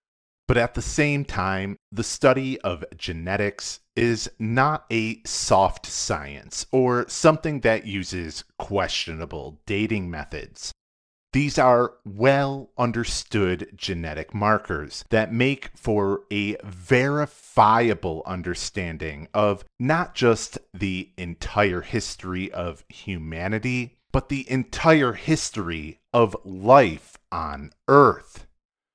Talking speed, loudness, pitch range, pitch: 100 wpm, -23 LUFS, 90-125 Hz, 110 Hz